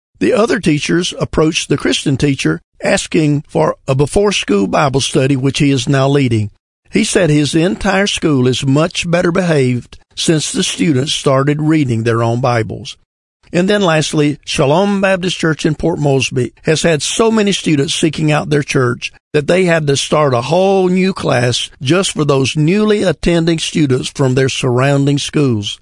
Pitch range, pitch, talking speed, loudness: 135-170 Hz, 150 Hz, 170 wpm, -13 LUFS